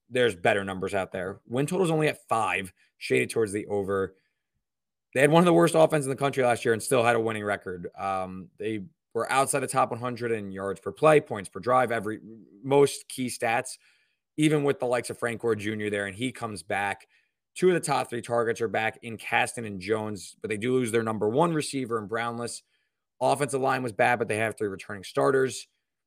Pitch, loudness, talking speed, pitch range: 115 Hz, -27 LUFS, 220 wpm, 105-135 Hz